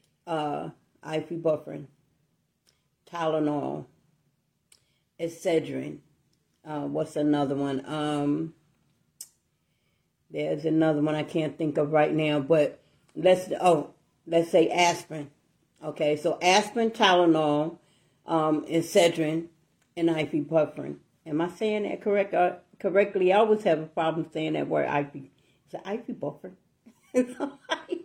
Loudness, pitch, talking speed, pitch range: -26 LUFS, 160 Hz, 110 wpm, 150-180 Hz